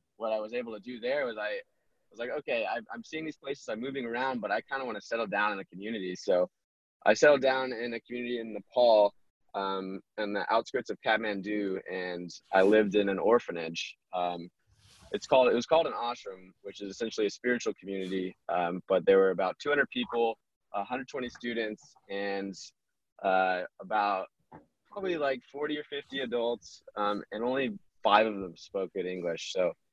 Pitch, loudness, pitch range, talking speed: 105 Hz, -31 LUFS, 95-125 Hz, 190 wpm